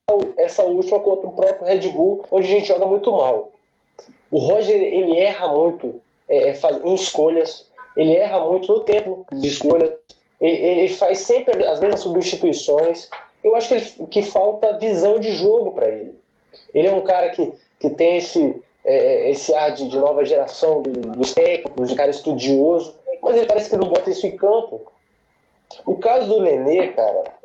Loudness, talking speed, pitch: -18 LUFS, 180 wpm, 210 Hz